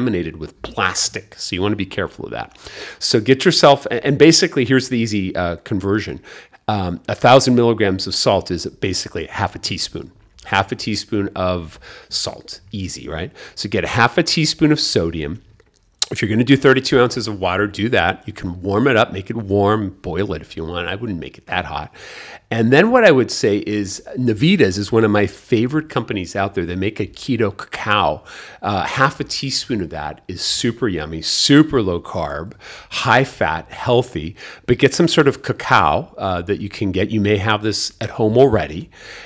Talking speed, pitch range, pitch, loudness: 195 wpm, 95-125 Hz, 105 Hz, -17 LUFS